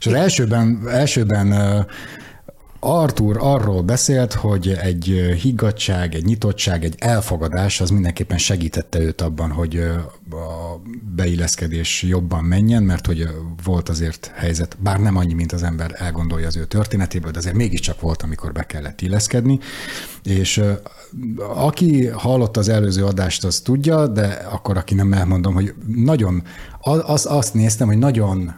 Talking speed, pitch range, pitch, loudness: 140 wpm, 85-115 Hz, 95 Hz, -19 LUFS